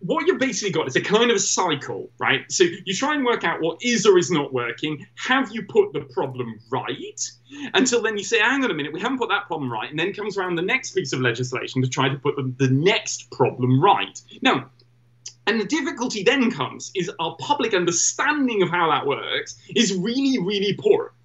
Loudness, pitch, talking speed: -22 LUFS, 190 Hz, 225 wpm